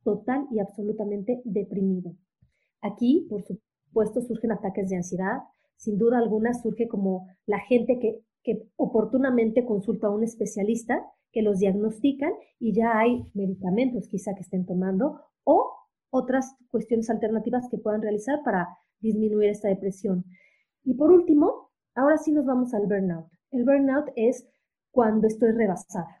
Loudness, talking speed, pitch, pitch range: -26 LUFS, 140 wpm, 220 Hz, 200-250 Hz